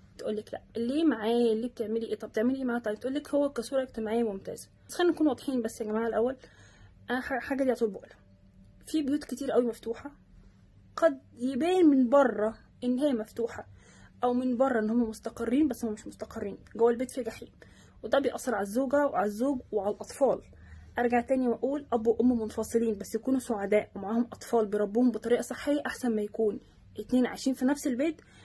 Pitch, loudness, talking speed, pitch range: 235 Hz, -29 LUFS, 180 wpm, 220-265 Hz